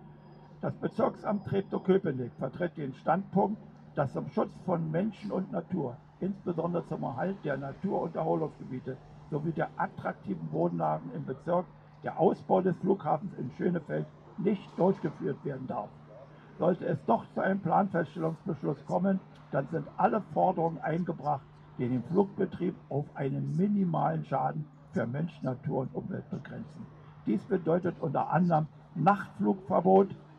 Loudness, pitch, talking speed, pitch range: -32 LUFS, 165 Hz, 130 wpm, 145-190 Hz